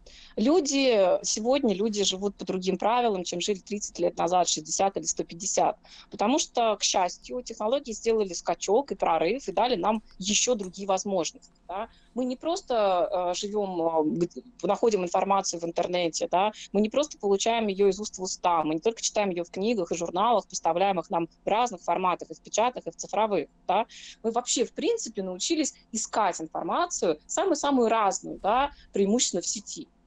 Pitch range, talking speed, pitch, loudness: 185-235 Hz, 170 wpm, 205 Hz, -27 LUFS